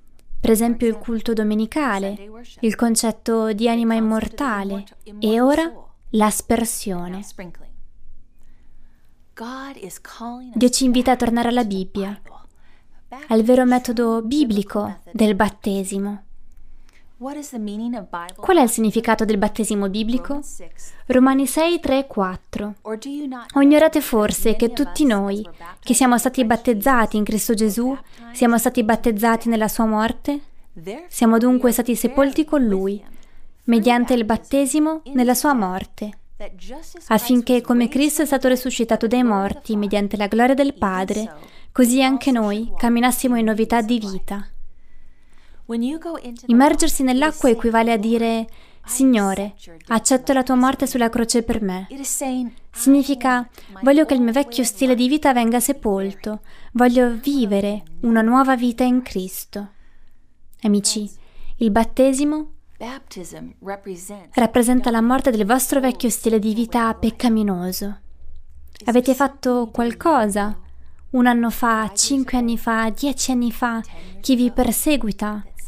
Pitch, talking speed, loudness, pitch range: 235 Hz, 120 wpm, -19 LUFS, 215-255 Hz